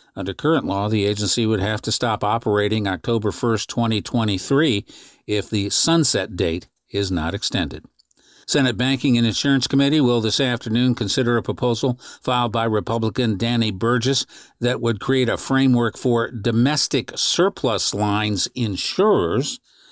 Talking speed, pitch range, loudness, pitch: 140 wpm, 105-125 Hz, -20 LUFS, 115 Hz